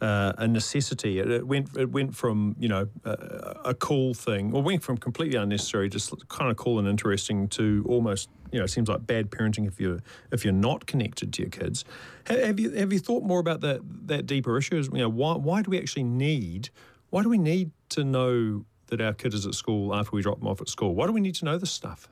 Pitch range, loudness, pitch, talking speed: 105-150 Hz, -27 LUFS, 120 Hz, 245 wpm